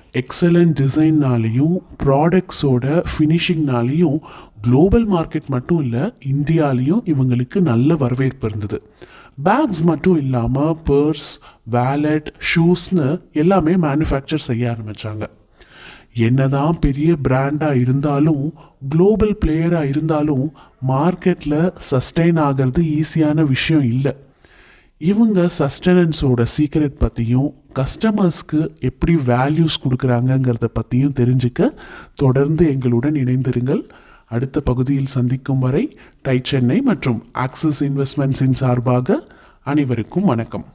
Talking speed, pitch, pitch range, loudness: 90 wpm, 140 Hz, 130-160 Hz, -17 LUFS